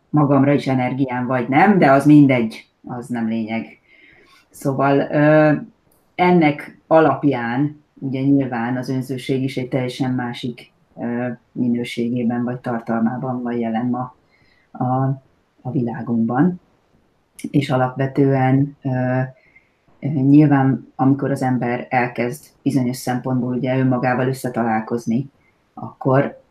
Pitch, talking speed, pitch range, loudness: 130 Hz, 100 wpm, 125-140 Hz, -19 LUFS